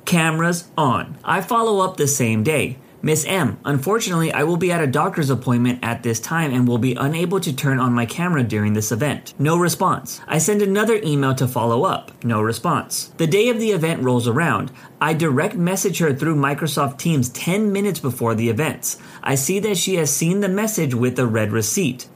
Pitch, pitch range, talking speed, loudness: 150 Hz, 125-180 Hz, 205 wpm, -19 LUFS